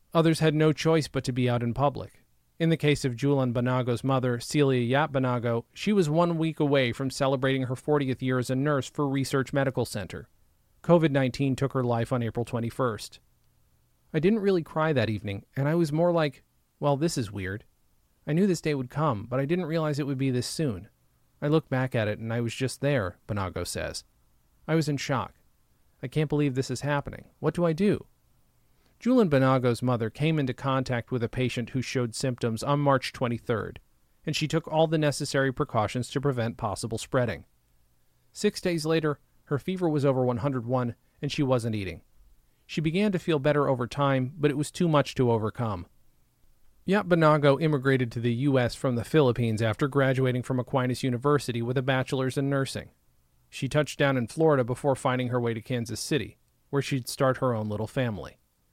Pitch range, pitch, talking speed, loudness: 120-150 Hz, 130 Hz, 195 wpm, -27 LUFS